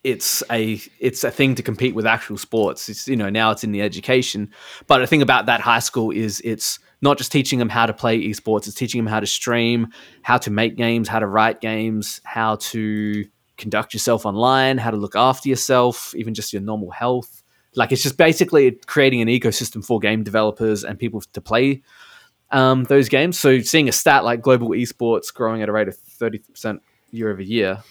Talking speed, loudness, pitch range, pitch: 210 wpm, -19 LUFS, 110-125 Hz, 115 Hz